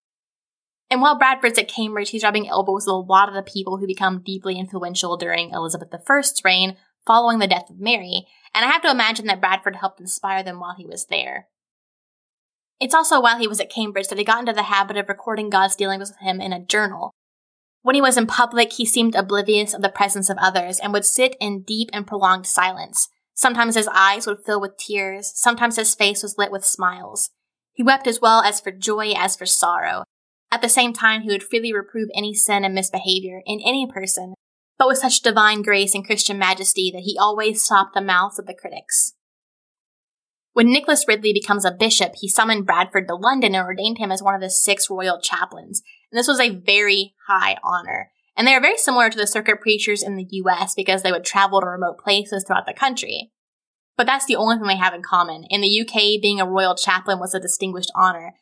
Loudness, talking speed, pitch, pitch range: -18 LUFS, 215 wpm, 200 Hz, 190-225 Hz